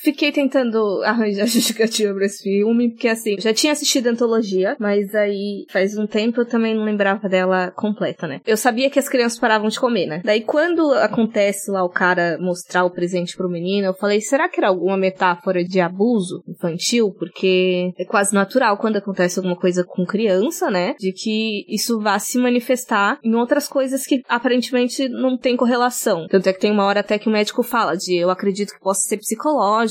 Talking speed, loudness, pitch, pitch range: 200 wpm, -19 LUFS, 210 Hz, 190-240 Hz